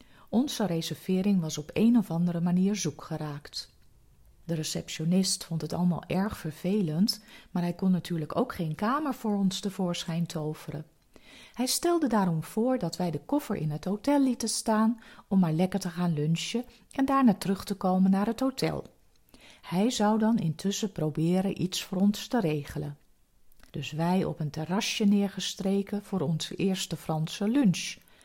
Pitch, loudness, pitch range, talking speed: 190 Hz, -29 LUFS, 165-210 Hz, 165 wpm